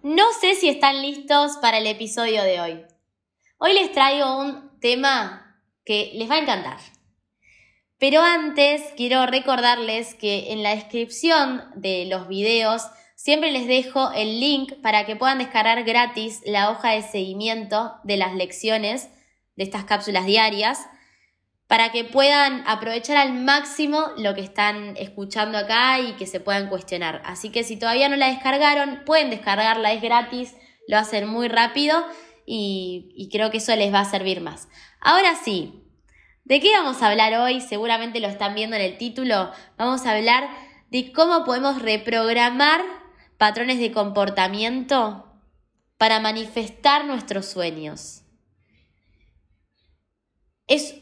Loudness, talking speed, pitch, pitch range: -20 LUFS, 145 wpm, 225 Hz, 205-270 Hz